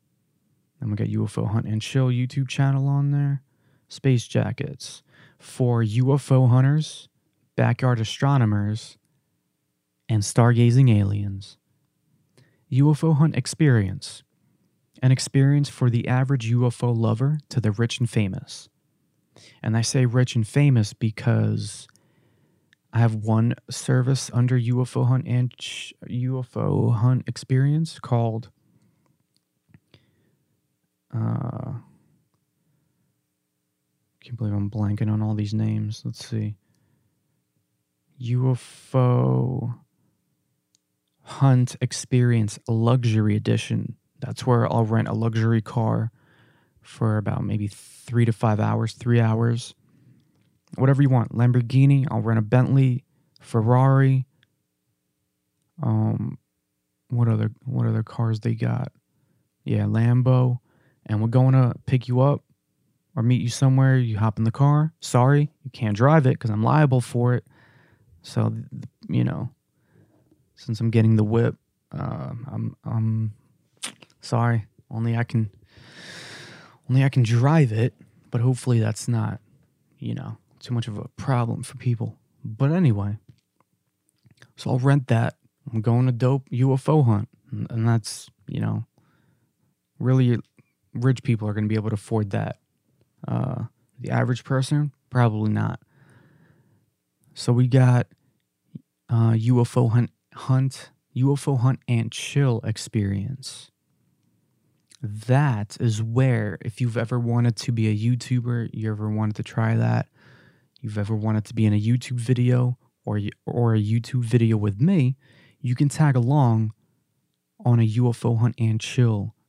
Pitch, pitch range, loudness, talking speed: 120 Hz, 110-135 Hz, -23 LUFS, 130 wpm